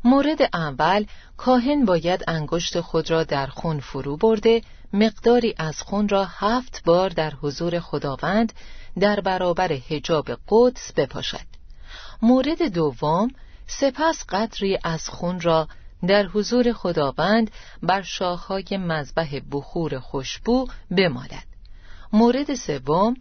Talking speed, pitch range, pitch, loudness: 110 wpm, 160-225 Hz, 185 Hz, -22 LUFS